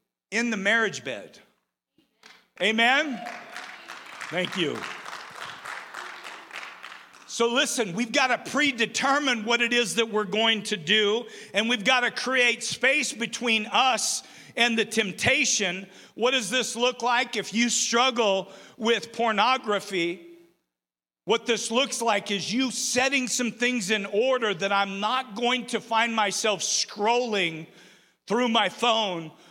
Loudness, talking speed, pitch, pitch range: -24 LUFS, 130 wpm, 230 Hz, 205-245 Hz